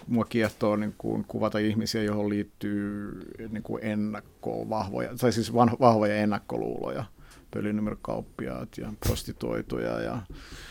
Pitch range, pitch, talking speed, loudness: 105-115 Hz, 105 Hz, 120 wpm, -29 LUFS